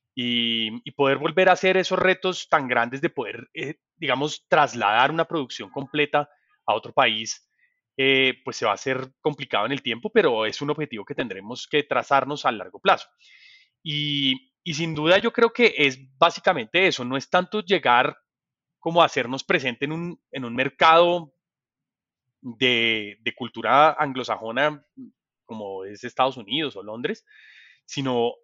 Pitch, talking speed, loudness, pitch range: 140 Hz, 160 wpm, -22 LUFS, 125-165 Hz